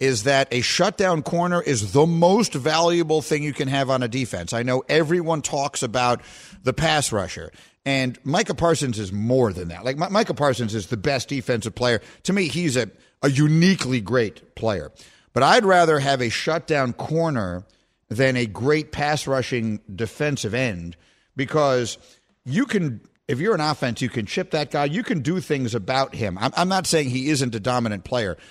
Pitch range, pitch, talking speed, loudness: 120-160 Hz, 135 Hz, 185 wpm, -22 LUFS